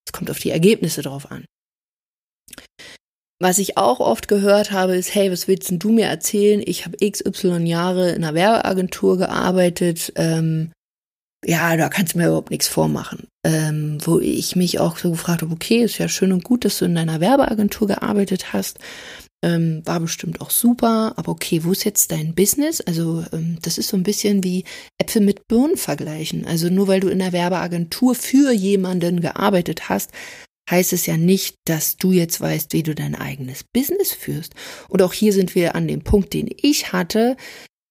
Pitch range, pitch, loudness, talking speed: 165-205 Hz, 185 Hz, -19 LUFS, 185 wpm